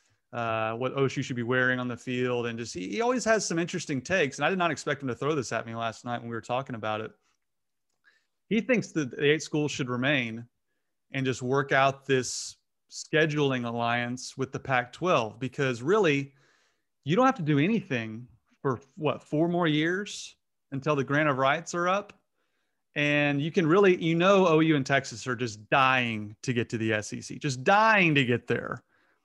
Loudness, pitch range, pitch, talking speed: -27 LUFS, 120-155 Hz, 135 Hz, 200 wpm